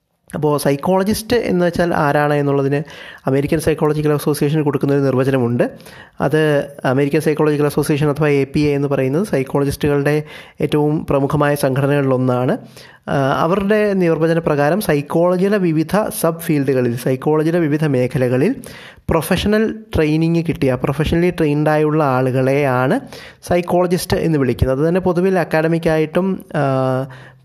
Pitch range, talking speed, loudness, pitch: 140-165 Hz, 105 wpm, -17 LUFS, 150 Hz